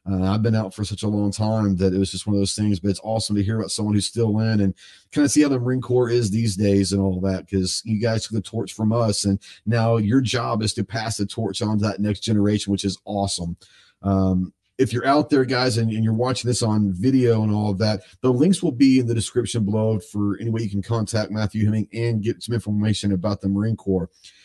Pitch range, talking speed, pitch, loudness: 100-115 Hz, 265 wpm, 105 Hz, -22 LUFS